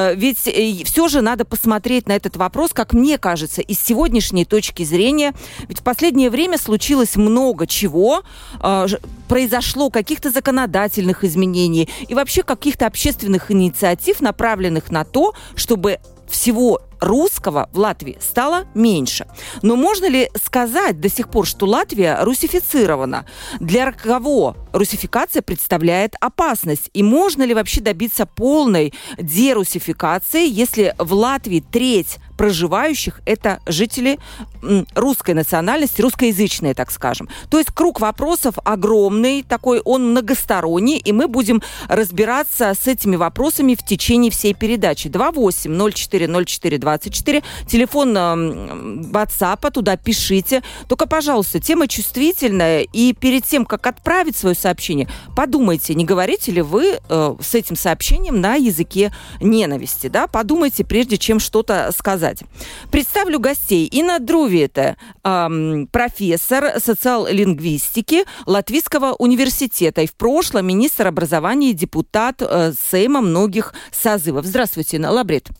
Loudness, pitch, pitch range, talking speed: -17 LUFS, 220 Hz, 185-260 Hz, 120 wpm